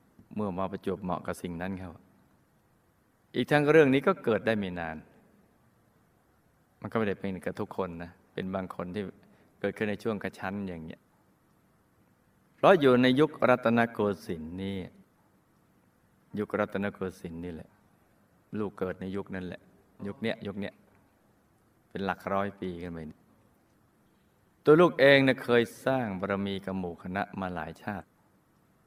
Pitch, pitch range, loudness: 95 Hz, 90-110 Hz, -29 LUFS